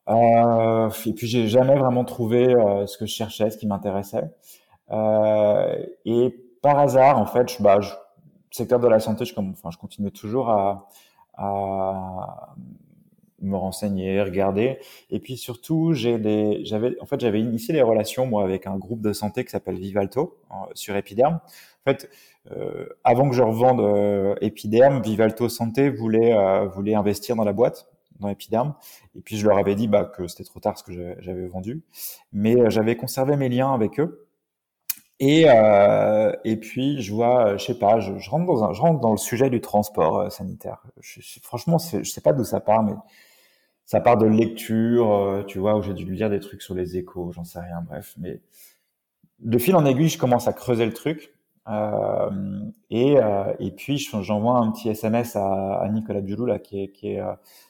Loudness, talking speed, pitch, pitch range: -22 LUFS, 195 wpm, 110 Hz, 100-125 Hz